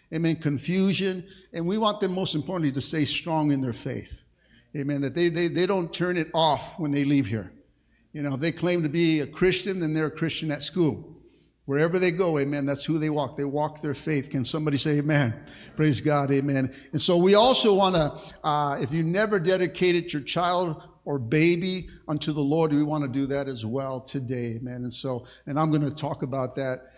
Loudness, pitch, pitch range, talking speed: -25 LUFS, 155 Hz, 140-175 Hz, 215 wpm